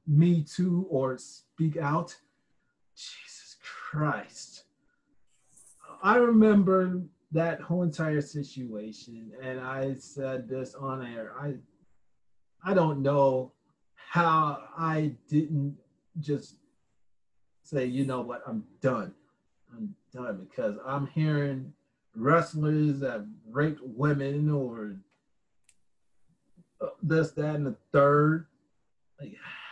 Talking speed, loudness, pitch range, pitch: 100 wpm, -28 LUFS, 130-165 Hz, 145 Hz